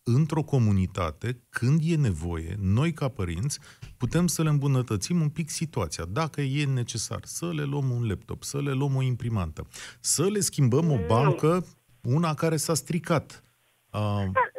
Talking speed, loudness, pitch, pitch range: 155 wpm, -27 LUFS, 135 Hz, 110-155 Hz